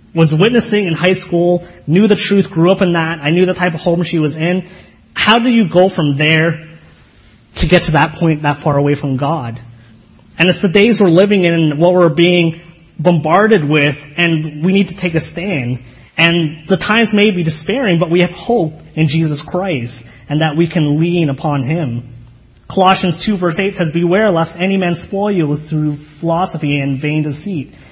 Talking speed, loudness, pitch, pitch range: 200 wpm, -13 LUFS, 170 Hz, 150-185 Hz